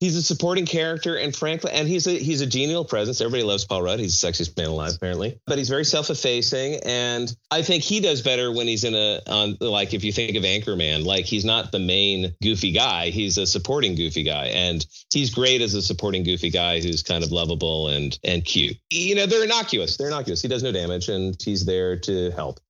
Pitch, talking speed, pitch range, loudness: 105 Hz, 225 wpm, 90-140 Hz, -22 LUFS